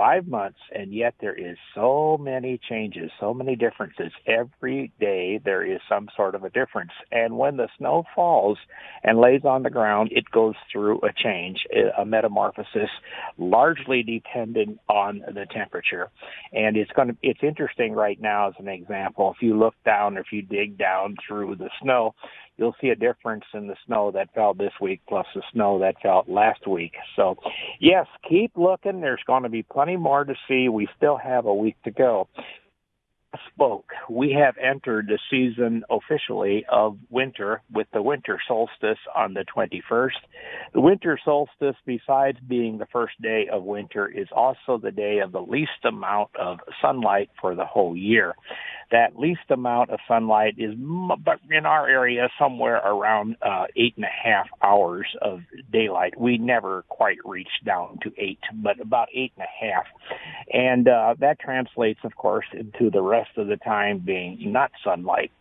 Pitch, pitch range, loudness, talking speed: 115 Hz, 105-130 Hz, -23 LUFS, 175 wpm